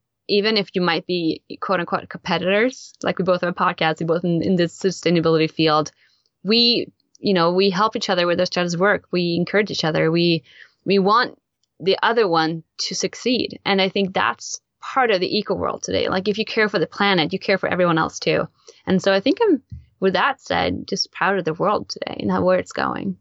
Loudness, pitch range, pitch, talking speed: -20 LUFS, 170-200 Hz, 185 Hz, 220 wpm